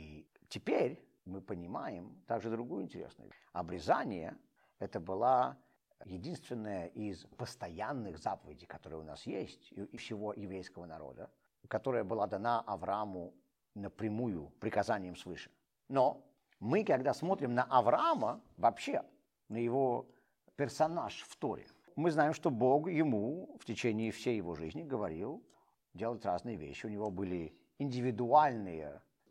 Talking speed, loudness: 120 wpm, -36 LUFS